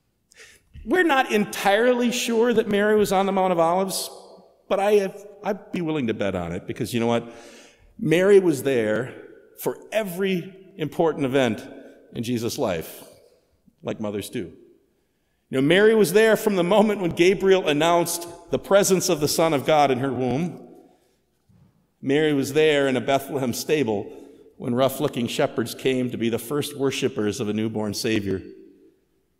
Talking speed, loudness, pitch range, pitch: 165 wpm, -22 LUFS, 125-200 Hz, 155 Hz